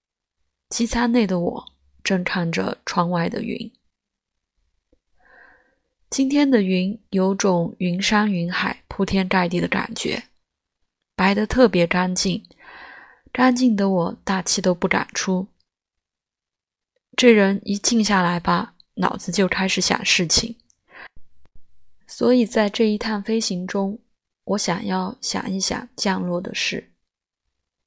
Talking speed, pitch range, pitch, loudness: 170 characters per minute, 180-225 Hz, 195 Hz, -21 LUFS